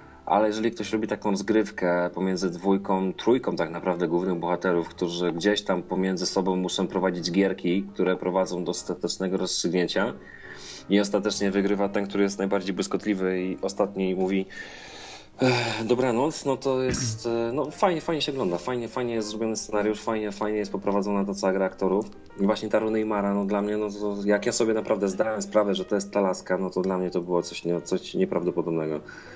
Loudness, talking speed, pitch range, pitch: -26 LUFS, 185 wpm, 95-110 Hz, 100 Hz